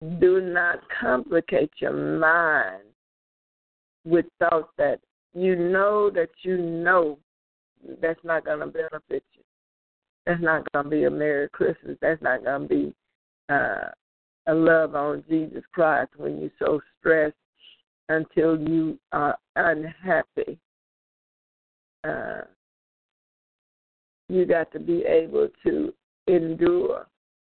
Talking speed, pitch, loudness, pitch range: 120 wpm, 165 Hz, -24 LUFS, 150-185 Hz